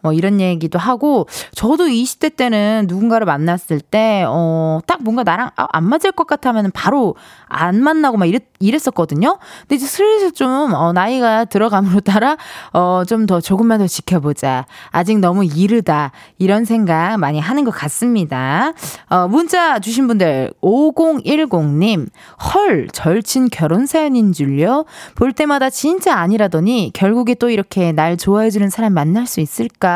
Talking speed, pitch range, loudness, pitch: 295 characters per minute, 175-260 Hz, -15 LUFS, 215 Hz